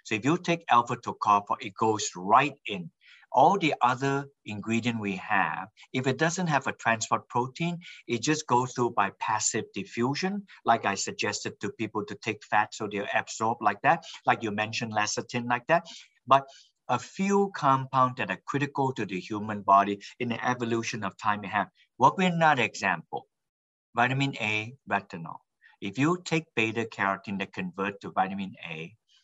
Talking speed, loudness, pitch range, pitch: 175 wpm, -28 LUFS, 105-135 Hz, 115 Hz